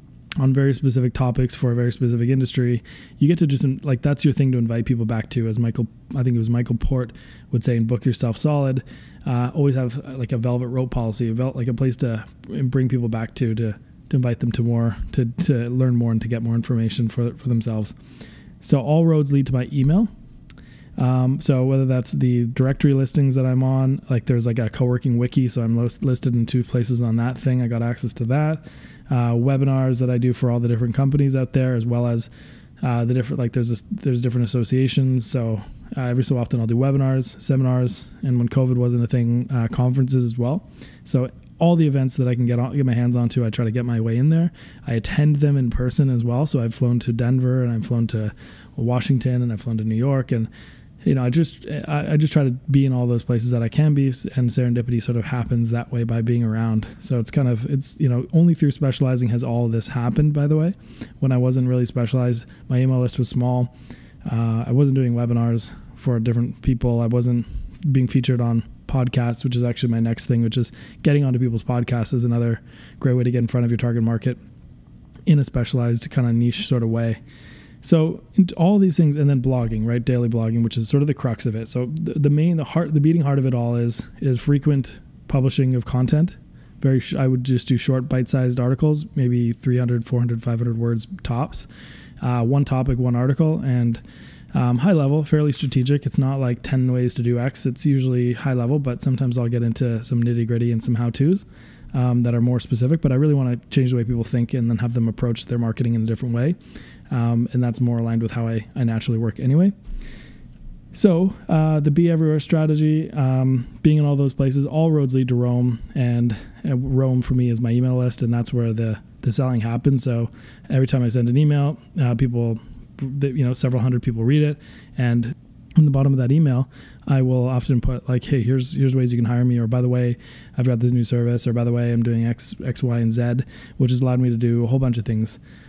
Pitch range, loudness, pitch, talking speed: 120-135 Hz, -21 LUFS, 125 Hz, 230 wpm